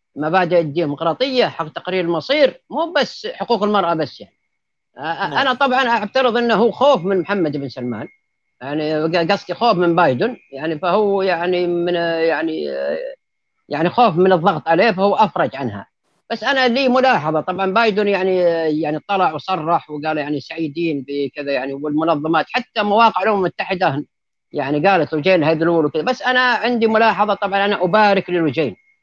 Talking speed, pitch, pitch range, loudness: 150 wpm, 180 Hz, 160-225 Hz, -17 LUFS